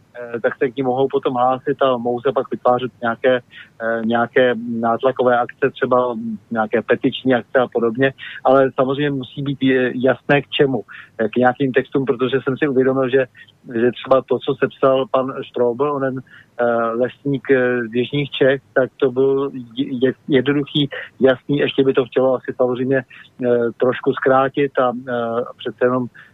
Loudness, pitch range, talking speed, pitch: -18 LUFS, 125-135 Hz, 150 wpm, 130 Hz